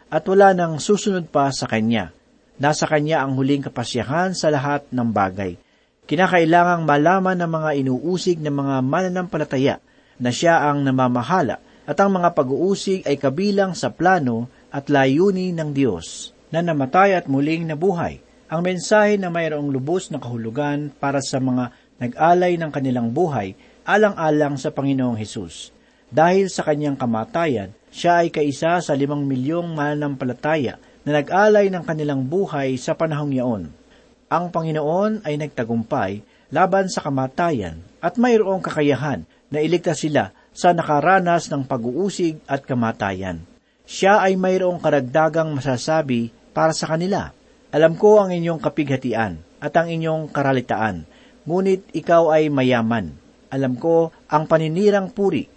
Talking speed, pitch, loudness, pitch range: 135 wpm, 155 Hz, -20 LUFS, 135-175 Hz